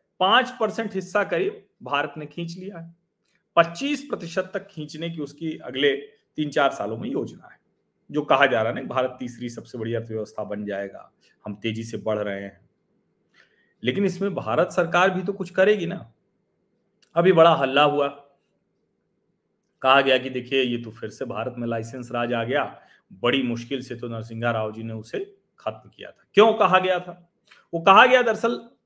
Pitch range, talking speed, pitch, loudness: 120-195 Hz, 185 wpm, 155 Hz, -23 LUFS